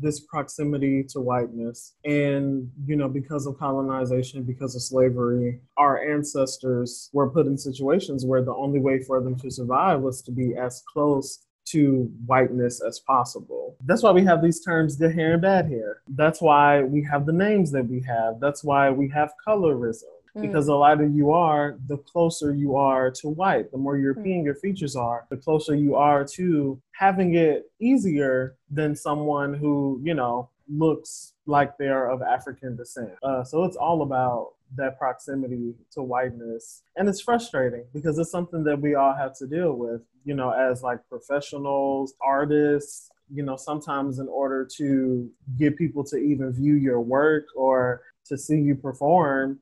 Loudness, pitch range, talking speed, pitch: -24 LUFS, 130-150 Hz, 175 wpm, 140 Hz